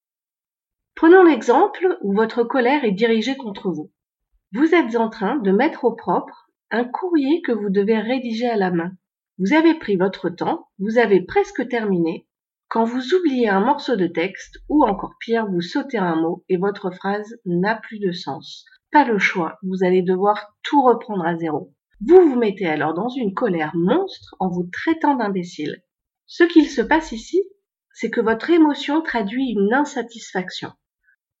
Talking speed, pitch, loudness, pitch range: 170 wpm, 225 Hz, -19 LUFS, 185-290 Hz